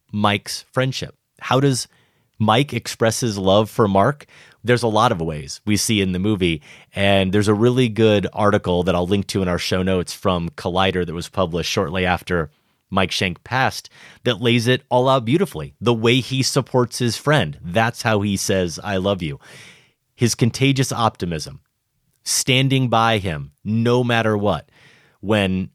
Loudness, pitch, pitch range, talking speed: -19 LUFS, 110 Hz, 95-125 Hz, 170 wpm